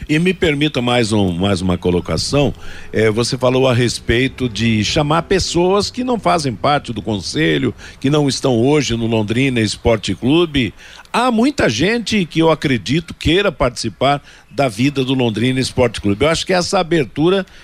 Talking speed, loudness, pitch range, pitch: 165 wpm, -16 LUFS, 115-165 Hz, 130 Hz